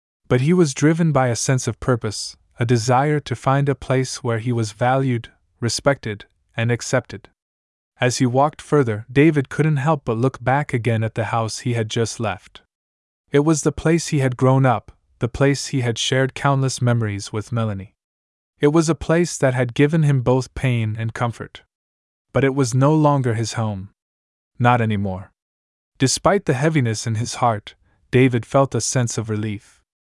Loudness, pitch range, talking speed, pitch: -20 LUFS, 105-135 Hz, 180 wpm, 120 Hz